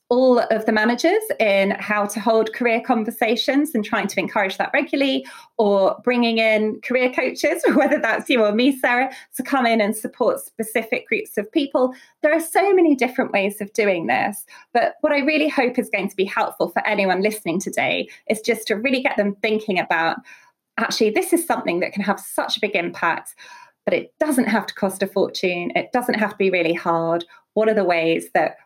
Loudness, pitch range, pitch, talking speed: -20 LUFS, 205-270 Hz, 230 Hz, 205 wpm